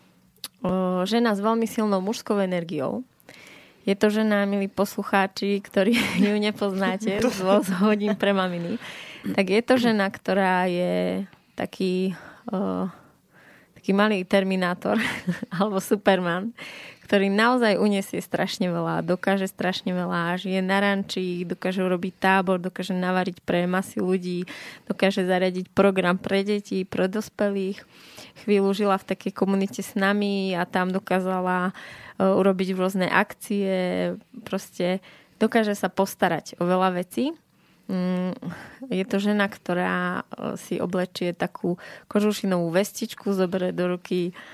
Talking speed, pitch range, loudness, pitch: 120 wpm, 185-205 Hz, -24 LUFS, 190 Hz